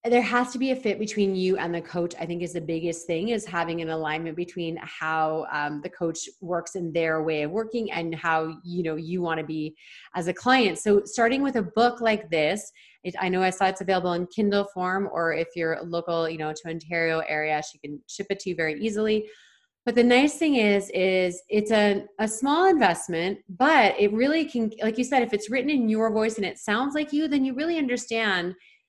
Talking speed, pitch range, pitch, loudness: 225 wpm, 165-225 Hz, 185 Hz, -25 LUFS